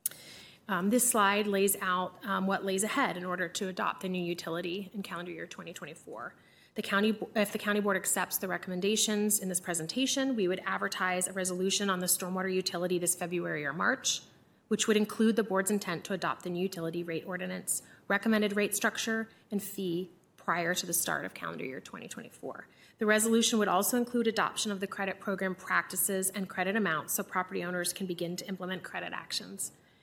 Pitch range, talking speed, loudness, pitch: 180-210 Hz, 190 wpm, -31 LUFS, 190 Hz